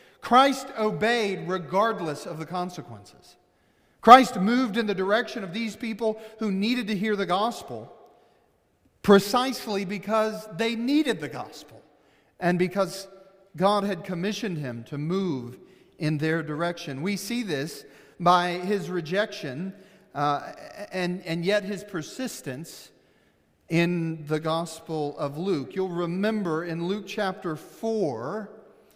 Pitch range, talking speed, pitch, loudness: 170-215 Hz, 125 wpm, 195 Hz, -26 LUFS